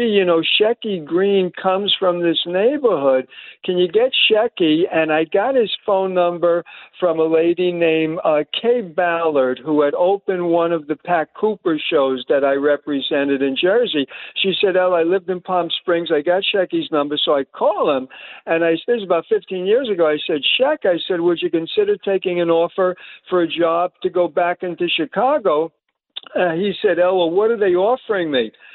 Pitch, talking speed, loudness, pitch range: 180 Hz, 195 wpm, -18 LUFS, 165-200 Hz